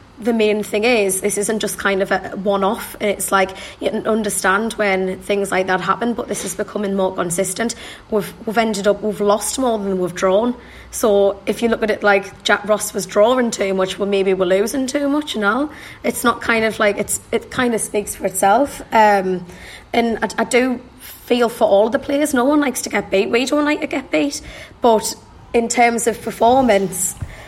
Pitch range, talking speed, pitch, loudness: 200-235 Hz, 210 wpm, 210 Hz, -18 LUFS